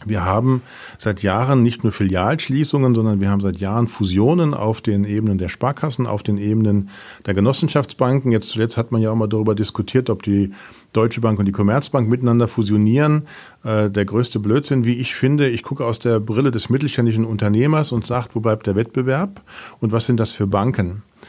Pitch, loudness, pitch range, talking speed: 115 Hz, -19 LUFS, 105-130 Hz, 190 wpm